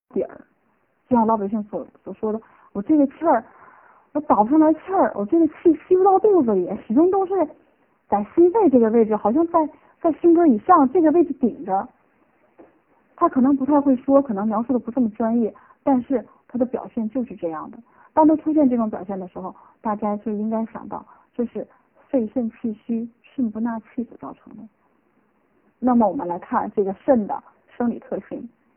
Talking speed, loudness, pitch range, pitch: 275 characters per minute, -20 LUFS, 220-310 Hz, 255 Hz